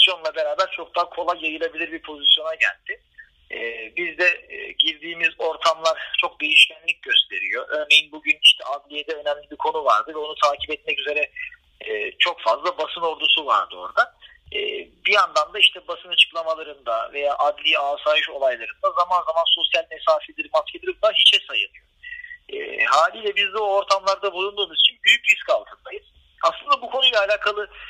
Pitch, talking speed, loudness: 200 Hz, 145 wpm, -20 LUFS